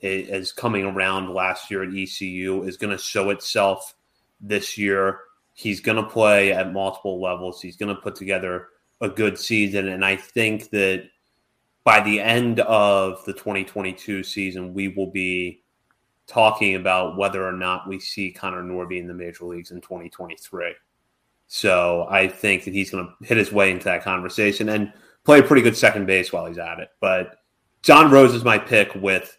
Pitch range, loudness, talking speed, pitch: 95-105 Hz, -20 LUFS, 180 wpm, 95 Hz